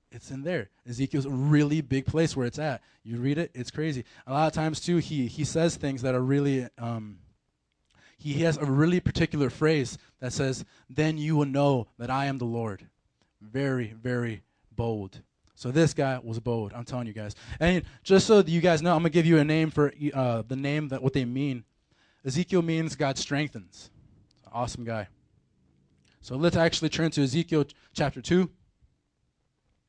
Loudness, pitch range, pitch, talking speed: -27 LUFS, 120-155 Hz, 140 Hz, 190 wpm